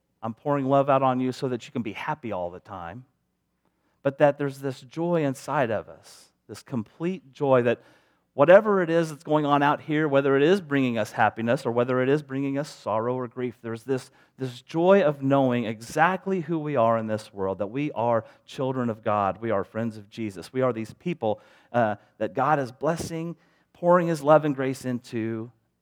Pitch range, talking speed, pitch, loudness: 115-150 Hz, 205 wpm, 130 Hz, -25 LUFS